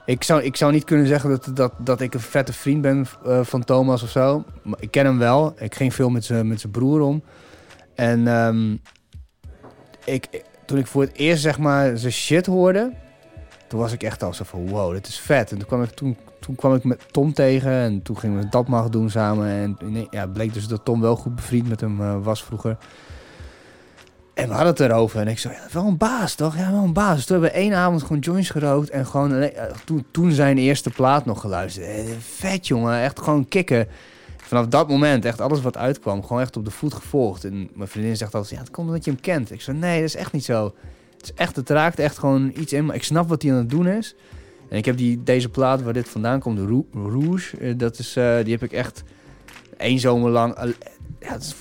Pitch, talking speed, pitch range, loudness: 125 Hz, 245 wpm, 115-145 Hz, -21 LUFS